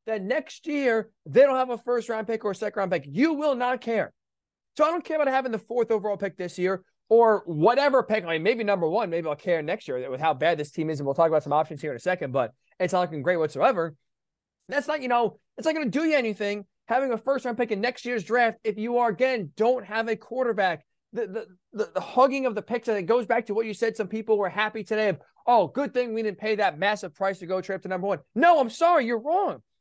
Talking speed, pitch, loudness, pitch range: 270 wpm, 220 Hz, -25 LUFS, 190-245 Hz